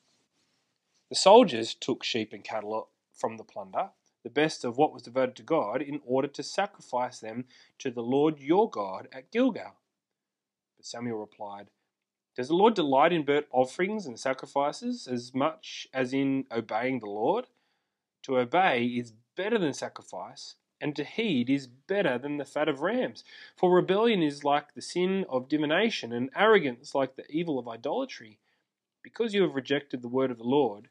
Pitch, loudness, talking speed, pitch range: 140 Hz, -28 LUFS, 170 wpm, 125-165 Hz